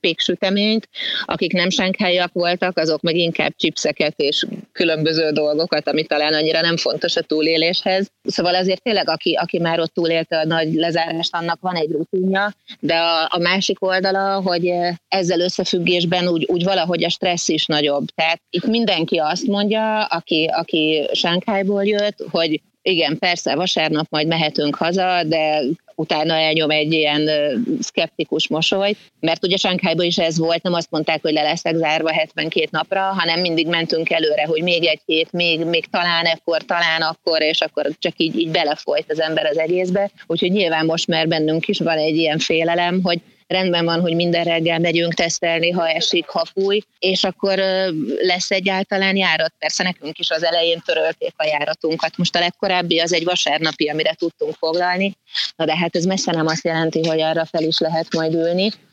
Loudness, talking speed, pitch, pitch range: -18 LUFS, 175 wpm, 170 Hz, 160-185 Hz